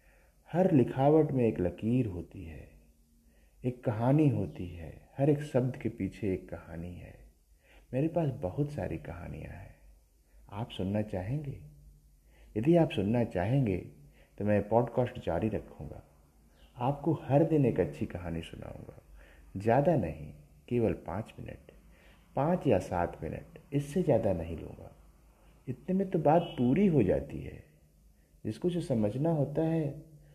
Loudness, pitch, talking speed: -31 LUFS, 105 Hz, 140 wpm